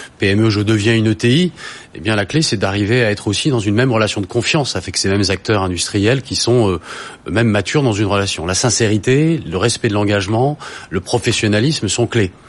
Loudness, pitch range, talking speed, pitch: -16 LUFS, 100-120 Hz, 210 wpm, 110 Hz